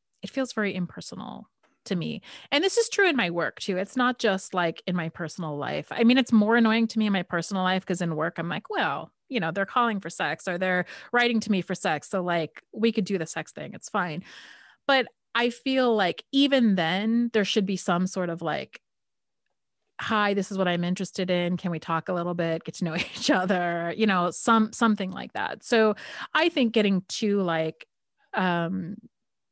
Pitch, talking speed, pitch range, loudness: 195 Hz, 215 wpm, 175-230 Hz, -26 LUFS